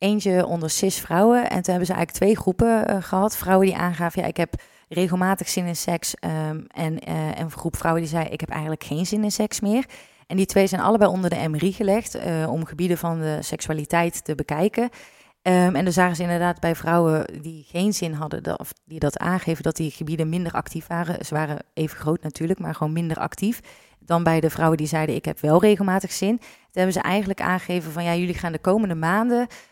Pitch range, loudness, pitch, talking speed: 160-190 Hz, -23 LUFS, 175 Hz, 220 wpm